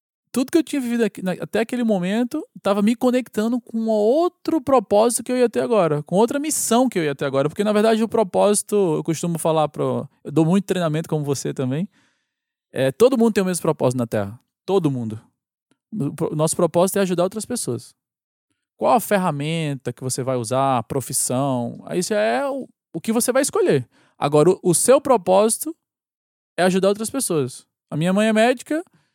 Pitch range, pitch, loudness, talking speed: 155-235 Hz, 200 Hz, -20 LUFS, 190 wpm